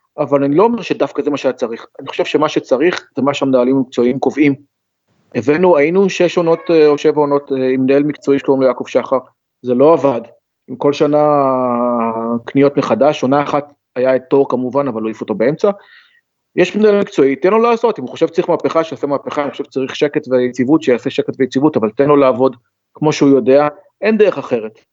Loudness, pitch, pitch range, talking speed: -14 LUFS, 140 Hz, 130-155 Hz, 190 wpm